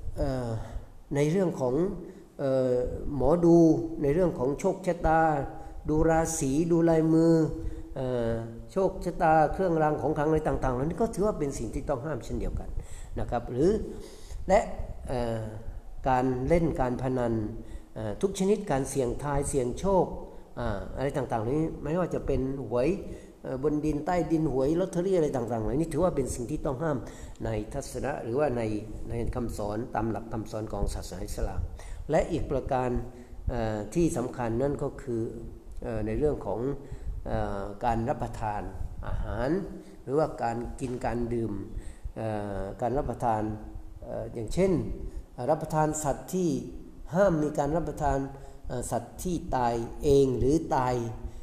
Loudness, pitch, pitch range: -29 LUFS, 130 Hz, 115-155 Hz